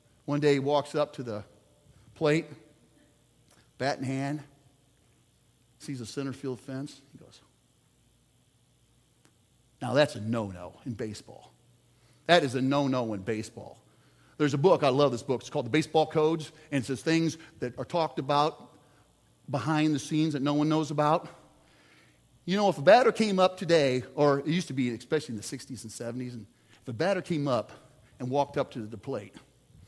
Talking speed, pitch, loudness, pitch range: 180 wpm, 140 Hz, -28 LUFS, 125-155 Hz